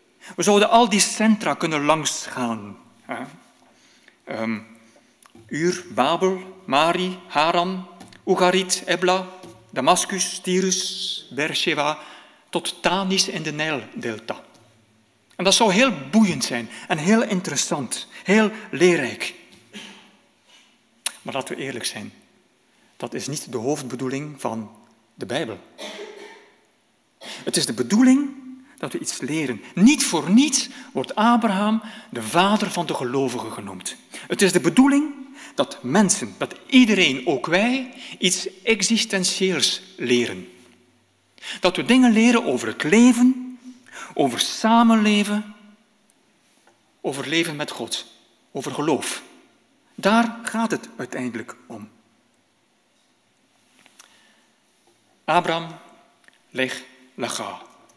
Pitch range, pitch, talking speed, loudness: 150-220 Hz, 185 Hz, 105 wpm, -21 LUFS